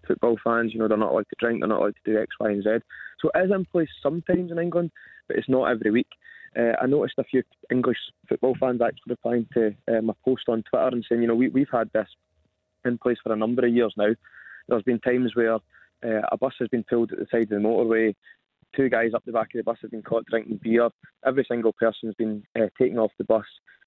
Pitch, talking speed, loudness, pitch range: 115 Hz, 255 wpm, -25 LUFS, 110-130 Hz